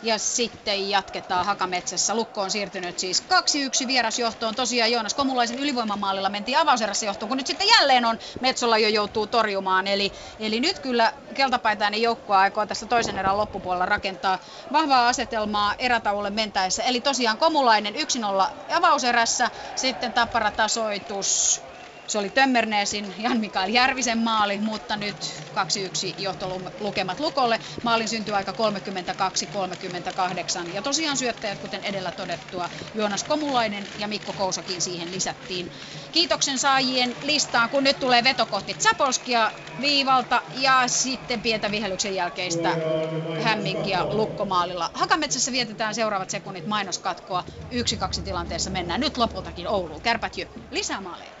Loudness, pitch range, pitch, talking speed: -23 LUFS, 195-245 Hz, 215 Hz, 130 wpm